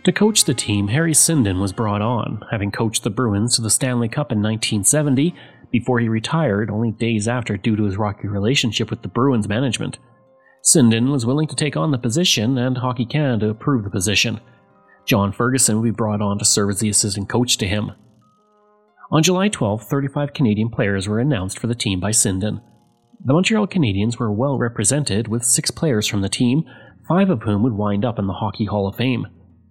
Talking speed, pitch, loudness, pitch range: 200 wpm, 115 Hz, -19 LUFS, 105-135 Hz